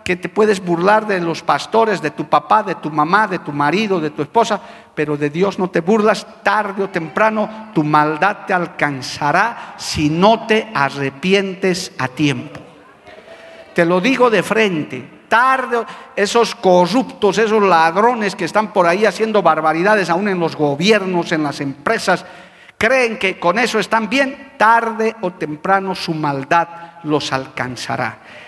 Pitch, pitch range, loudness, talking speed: 185 Hz, 160-215 Hz, -16 LUFS, 155 wpm